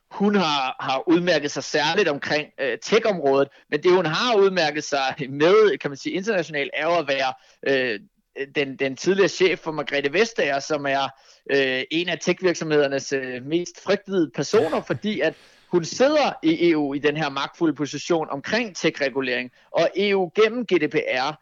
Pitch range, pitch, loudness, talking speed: 140-185 Hz, 155 Hz, -22 LUFS, 160 wpm